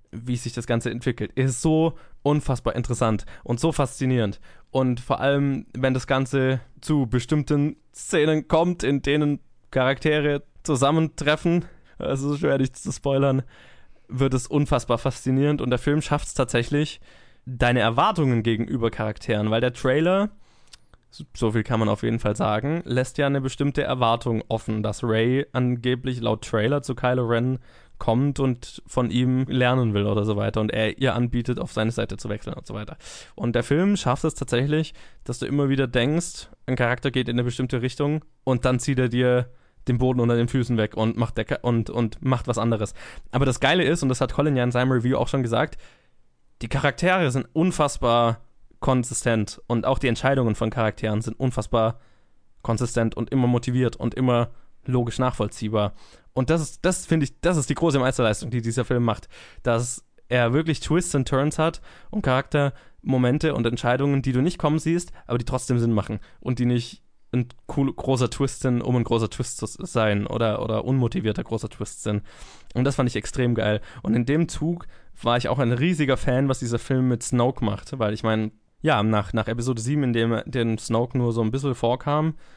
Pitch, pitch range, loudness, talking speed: 125 Hz, 115-140 Hz, -24 LUFS, 190 wpm